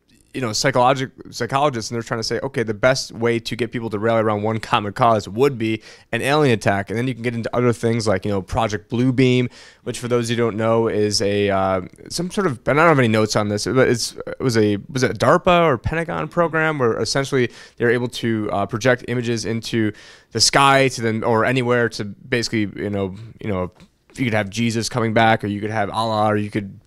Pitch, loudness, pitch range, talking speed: 115 Hz, -19 LUFS, 110-125 Hz, 240 wpm